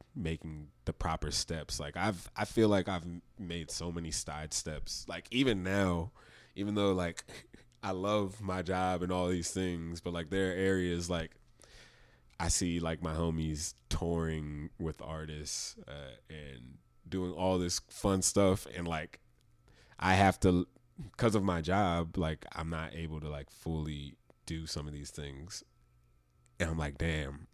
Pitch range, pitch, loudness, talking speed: 80-95 Hz, 85 Hz, -34 LUFS, 165 wpm